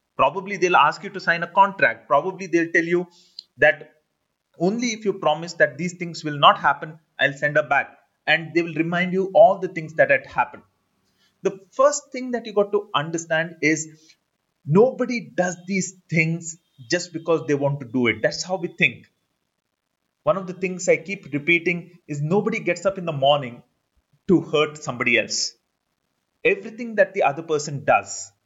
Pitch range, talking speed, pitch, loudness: 155-190 Hz, 180 wpm, 170 Hz, -21 LUFS